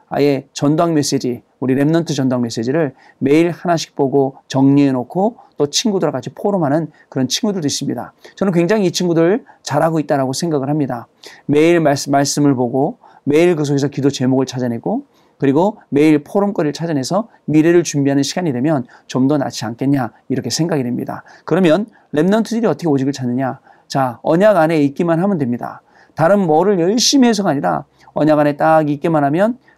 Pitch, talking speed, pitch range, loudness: 150 Hz, 385 characters per minute, 135-170 Hz, -16 LUFS